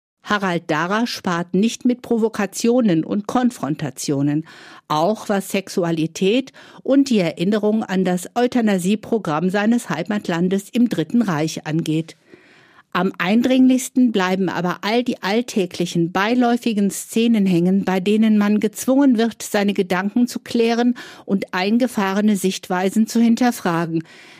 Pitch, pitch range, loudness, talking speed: 205 Hz, 180-235 Hz, -19 LUFS, 115 wpm